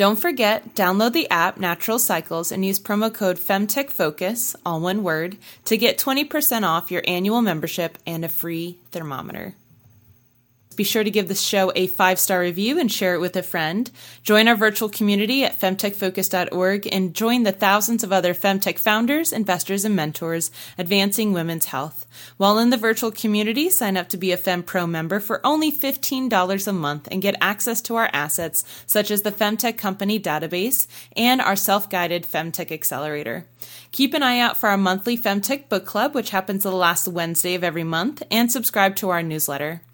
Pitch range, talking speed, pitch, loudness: 175-220 Hz, 180 wpm, 195 Hz, -20 LUFS